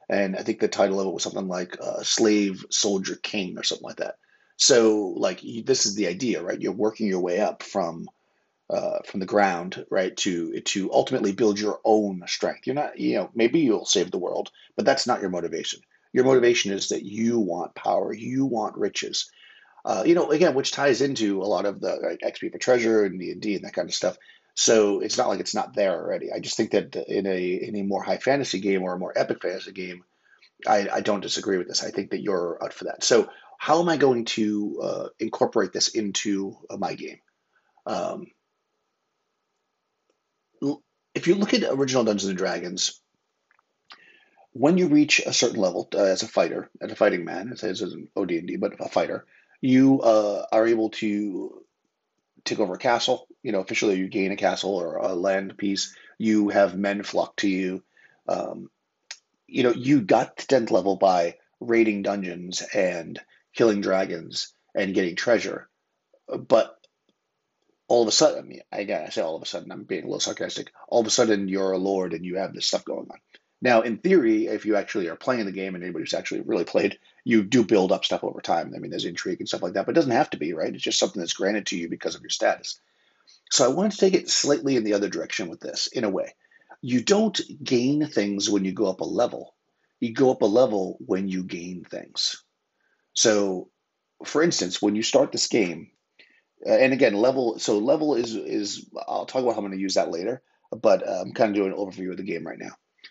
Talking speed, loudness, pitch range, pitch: 215 wpm, -24 LUFS, 95-135 Hz, 105 Hz